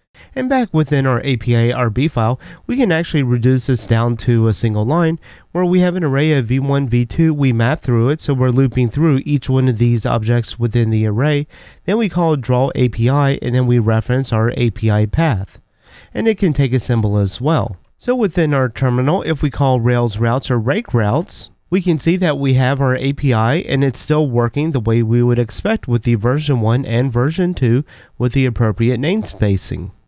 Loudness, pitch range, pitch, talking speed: -16 LUFS, 120-150 Hz, 130 Hz, 200 wpm